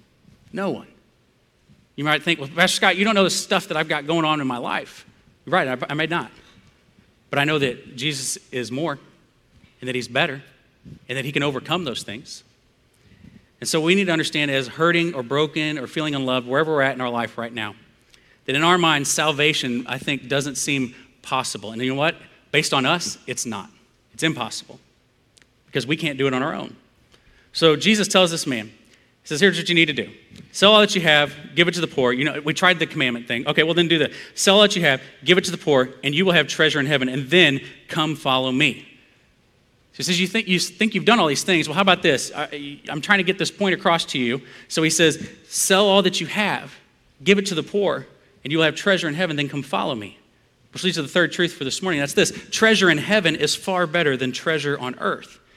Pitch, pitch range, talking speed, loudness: 155 Hz, 135-175 Hz, 240 wpm, -20 LUFS